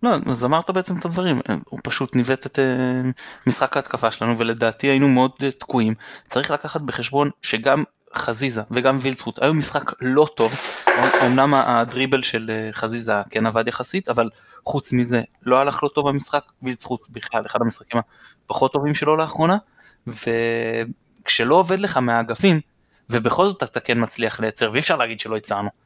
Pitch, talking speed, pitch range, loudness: 125 Hz, 155 wpm, 115-145 Hz, -21 LUFS